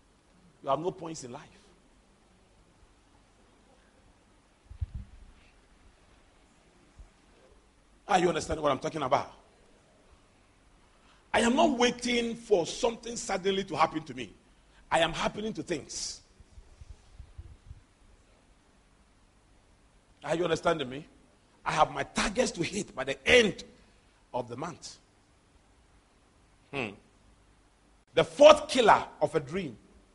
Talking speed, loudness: 105 wpm, -28 LUFS